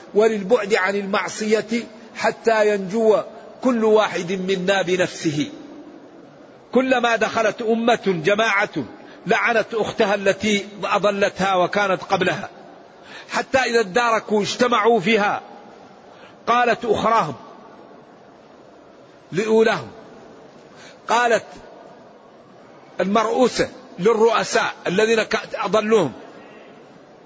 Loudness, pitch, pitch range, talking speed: -20 LUFS, 220 Hz, 200-230 Hz, 70 wpm